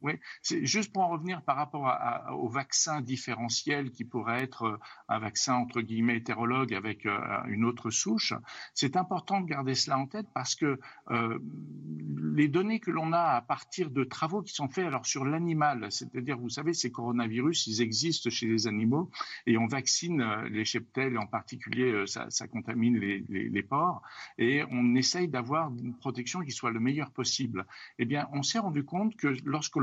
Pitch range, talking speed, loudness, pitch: 115-150 Hz, 190 wpm, -31 LUFS, 130 Hz